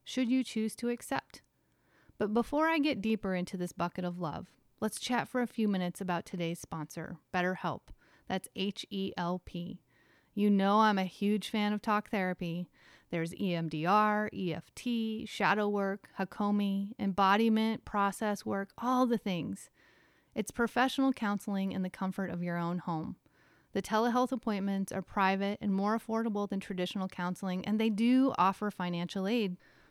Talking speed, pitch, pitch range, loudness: 155 wpm, 200 Hz, 185-220 Hz, -33 LUFS